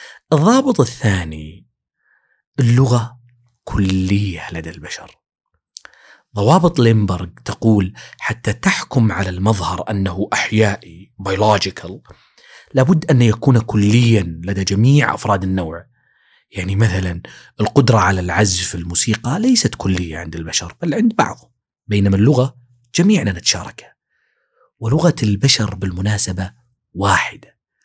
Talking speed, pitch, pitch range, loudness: 95 wpm, 105 Hz, 95-120 Hz, -16 LUFS